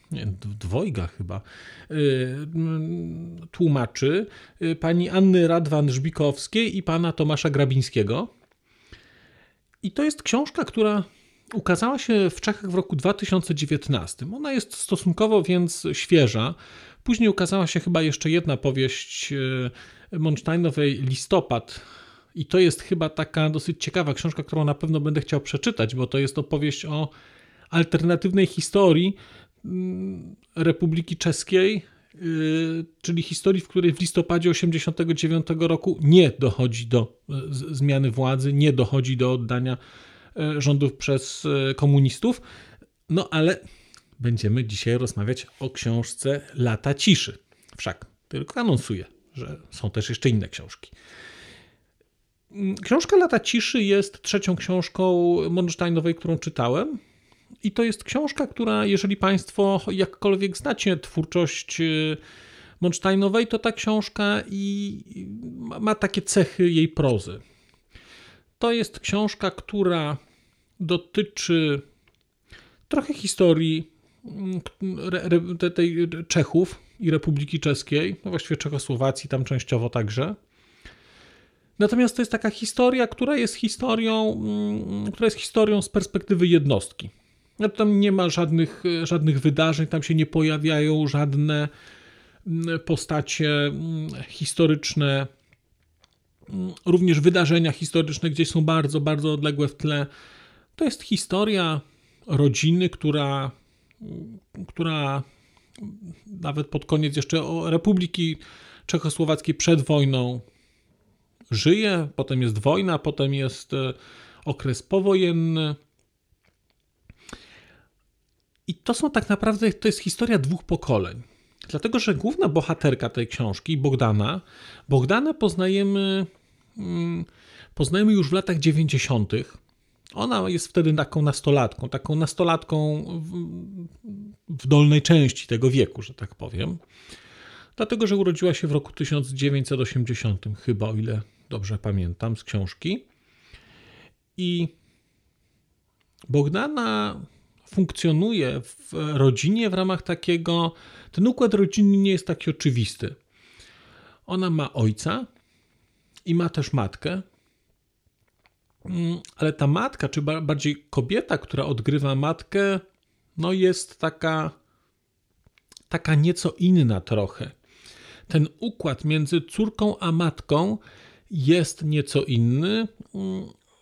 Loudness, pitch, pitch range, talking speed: -23 LUFS, 160 Hz, 135-185 Hz, 105 wpm